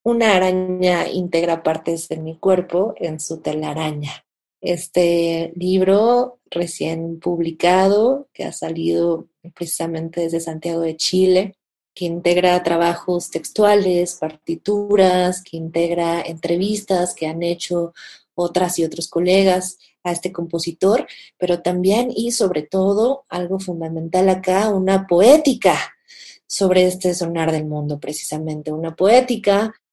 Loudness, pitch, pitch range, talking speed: -19 LUFS, 175 Hz, 165-190 Hz, 115 wpm